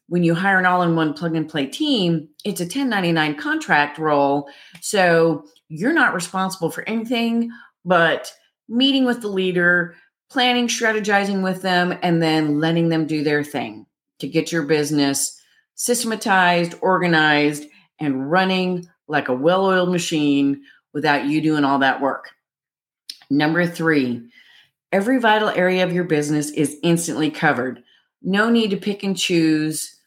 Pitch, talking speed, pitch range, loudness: 170 Hz, 150 wpm, 150-195 Hz, -19 LUFS